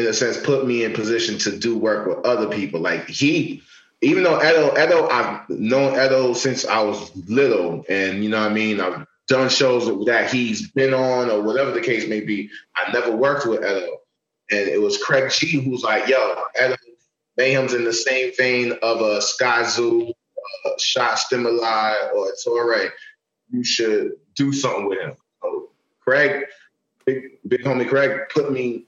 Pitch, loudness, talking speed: 130 Hz, -20 LUFS, 185 wpm